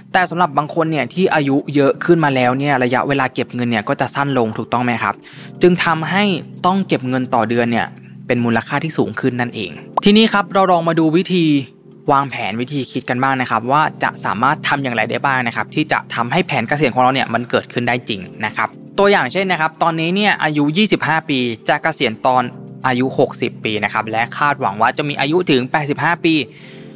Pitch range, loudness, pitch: 120-165 Hz, -16 LUFS, 140 Hz